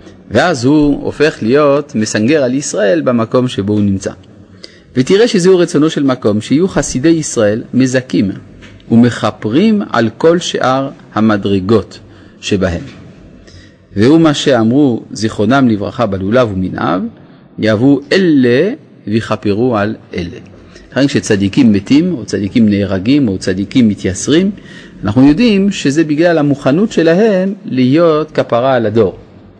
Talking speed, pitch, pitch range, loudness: 115 wpm, 125 Hz, 105-155 Hz, -12 LUFS